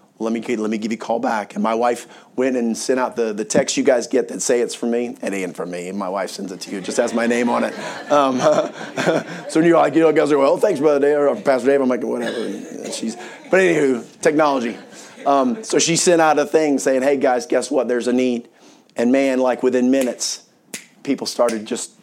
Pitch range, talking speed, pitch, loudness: 120-145 Hz, 245 wpm, 125 Hz, -19 LUFS